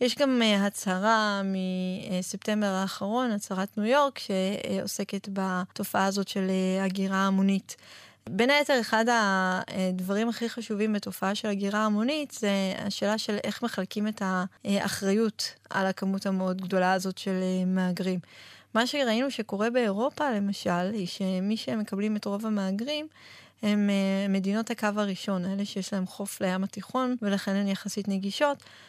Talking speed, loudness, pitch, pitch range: 130 wpm, -28 LUFS, 200 Hz, 190-220 Hz